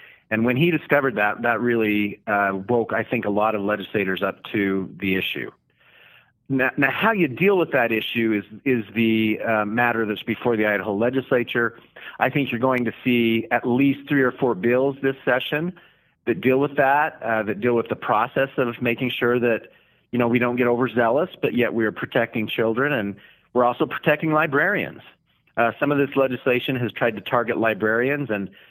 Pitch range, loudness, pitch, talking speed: 110-135 Hz, -22 LUFS, 120 Hz, 195 wpm